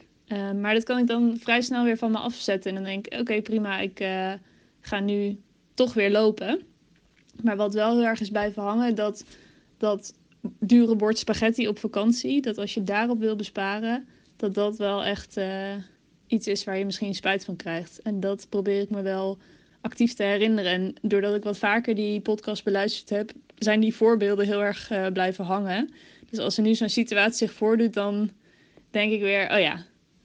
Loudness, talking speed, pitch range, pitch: -25 LUFS, 200 wpm, 200-225 Hz, 210 Hz